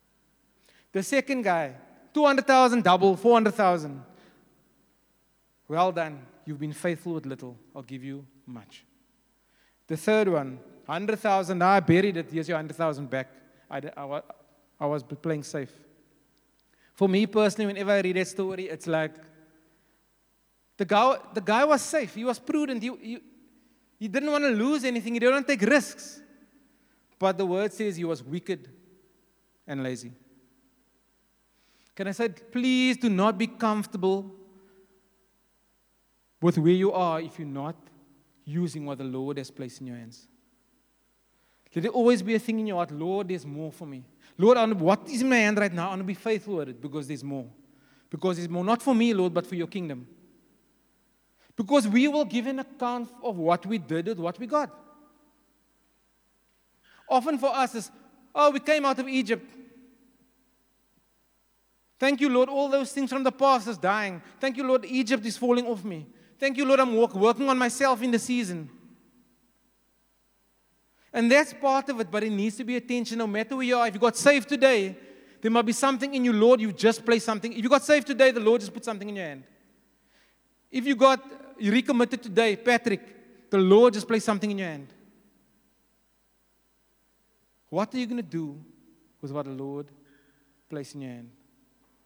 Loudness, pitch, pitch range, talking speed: -25 LUFS, 210 Hz, 160-255 Hz, 175 wpm